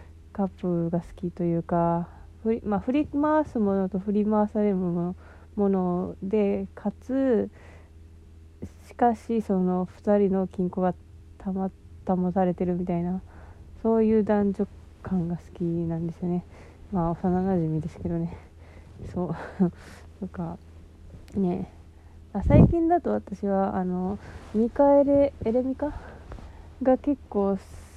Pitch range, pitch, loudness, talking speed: 165-205 Hz, 185 Hz, -26 LUFS, 230 characters per minute